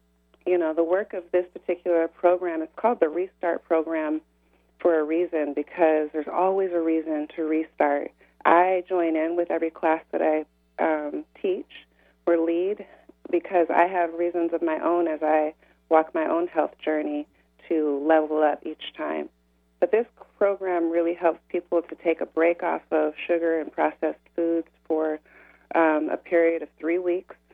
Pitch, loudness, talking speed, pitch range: 165 Hz, -25 LUFS, 170 wpm, 155-175 Hz